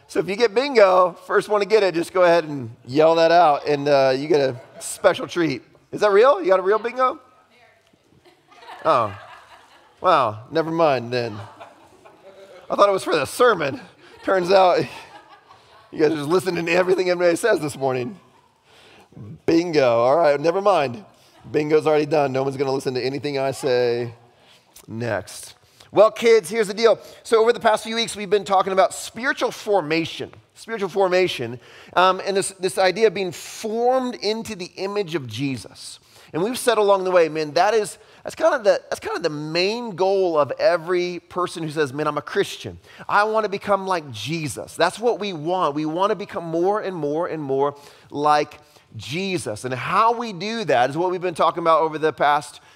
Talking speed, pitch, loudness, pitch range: 195 wpm, 175 Hz, -20 LUFS, 150-200 Hz